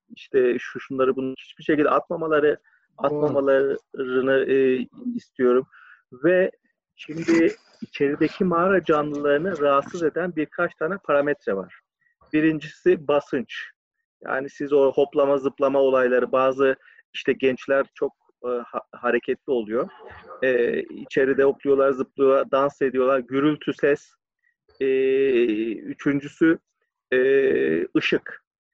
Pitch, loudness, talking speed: 150 Hz, -22 LUFS, 100 wpm